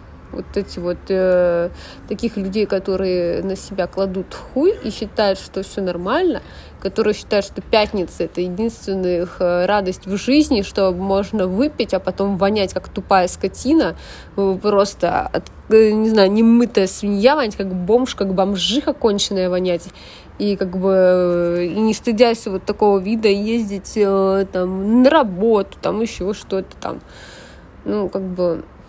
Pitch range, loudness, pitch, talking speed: 185-220 Hz, -18 LUFS, 195 Hz, 140 wpm